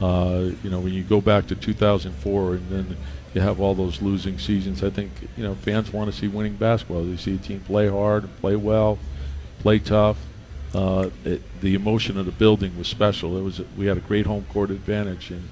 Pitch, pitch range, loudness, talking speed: 100 Hz, 90-105 Hz, -23 LUFS, 220 wpm